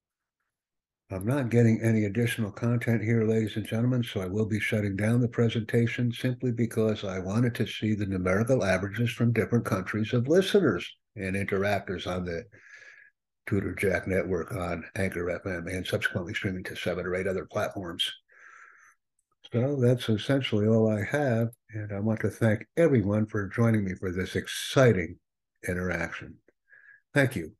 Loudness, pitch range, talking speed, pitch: -28 LUFS, 95-120 Hz, 155 wpm, 110 Hz